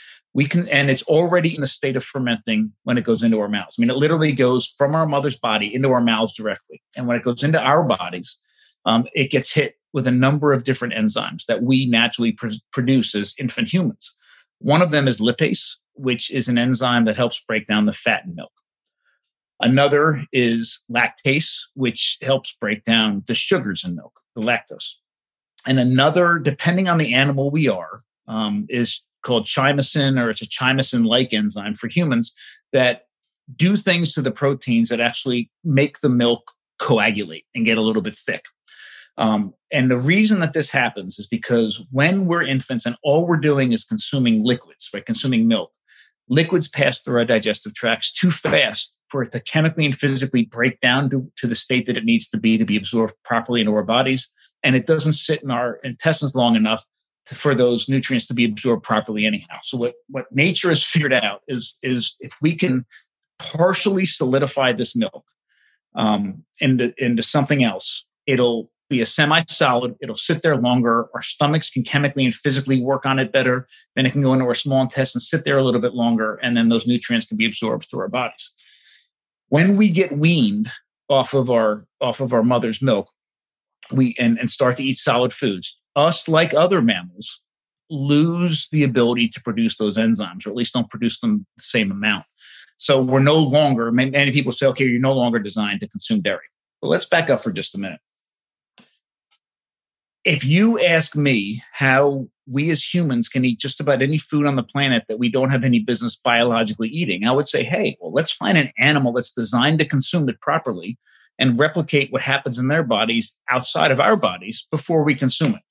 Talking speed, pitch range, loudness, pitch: 195 wpm, 120-150 Hz, -19 LUFS, 130 Hz